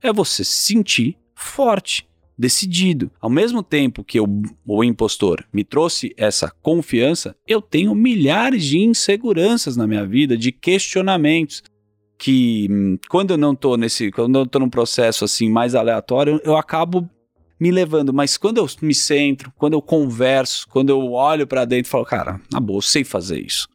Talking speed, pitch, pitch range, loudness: 170 wpm, 135 Hz, 115-170 Hz, -17 LUFS